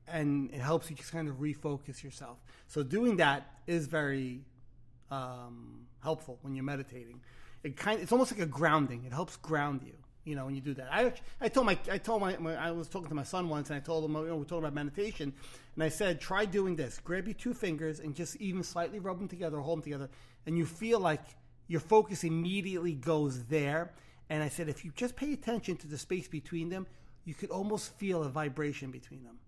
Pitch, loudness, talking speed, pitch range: 155 Hz, -35 LUFS, 230 wpm, 140-180 Hz